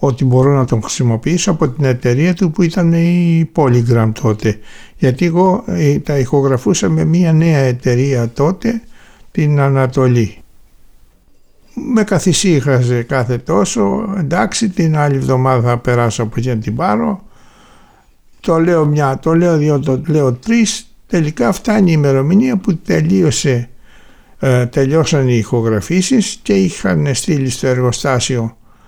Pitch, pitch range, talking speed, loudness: 145 Hz, 125-175 Hz, 130 wpm, -14 LUFS